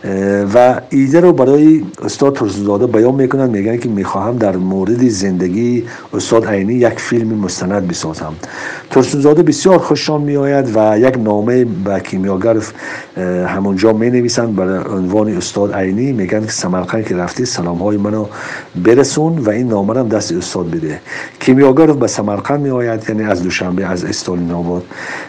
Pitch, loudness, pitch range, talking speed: 110 Hz, -13 LUFS, 95-125 Hz, 145 wpm